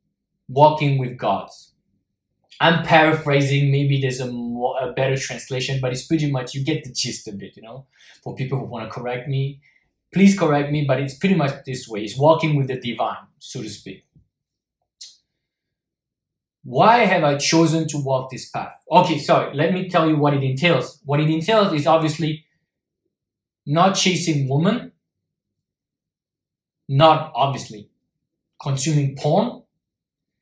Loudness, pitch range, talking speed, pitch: -19 LUFS, 130-160 Hz, 150 wpm, 145 Hz